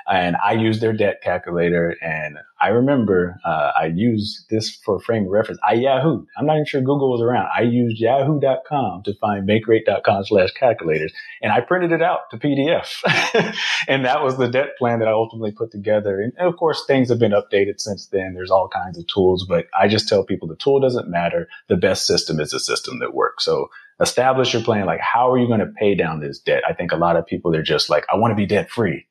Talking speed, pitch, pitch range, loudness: 230 wpm, 115 Hz, 100-135 Hz, -19 LUFS